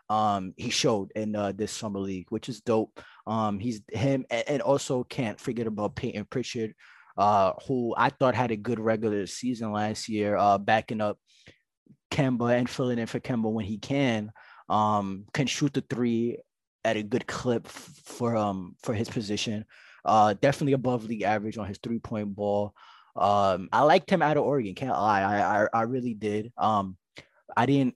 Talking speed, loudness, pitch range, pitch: 180 wpm, -27 LUFS, 105-125 Hz, 115 Hz